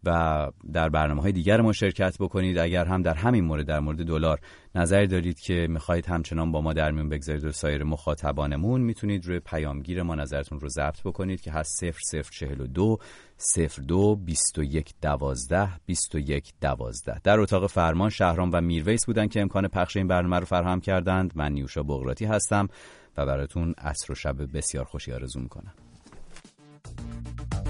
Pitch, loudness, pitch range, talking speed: 85 Hz, -27 LUFS, 75-95 Hz, 175 wpm